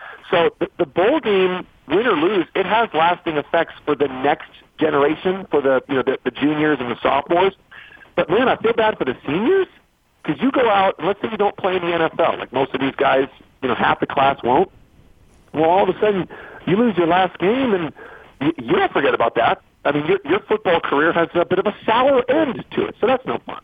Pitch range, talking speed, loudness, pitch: 145-220 Hz, 235 wpm, -19 LUFS, 175 Hz